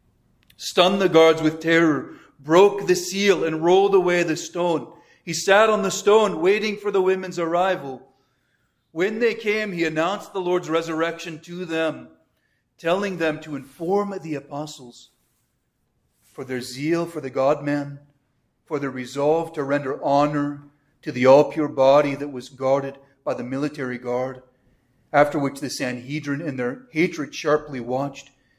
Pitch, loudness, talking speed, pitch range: 150 Hz, -21 LUFS, 155 wpm, 135-175 Hz